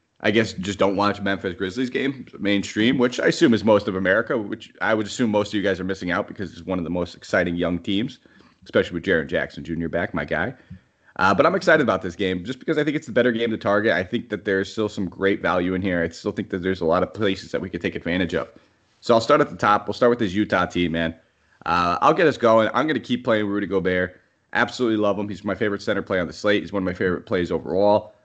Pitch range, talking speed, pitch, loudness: 90-110 Hz, 275 wpm, 100 Hz, -22 LUFS